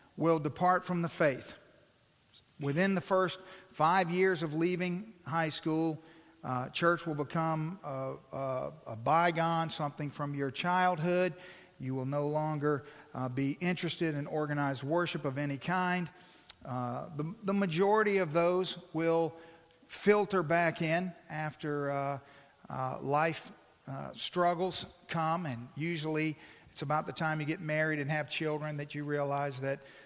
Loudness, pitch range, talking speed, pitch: -33 LUFS, 145-175 Hz, 145 wpm, 160 Hz